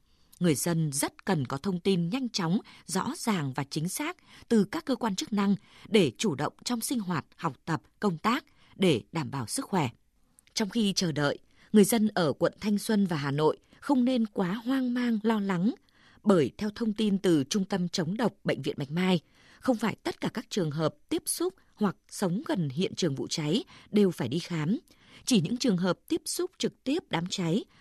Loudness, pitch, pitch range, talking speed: -29 LUFS, 200 Hz, 170-230 Hz, 210 wpm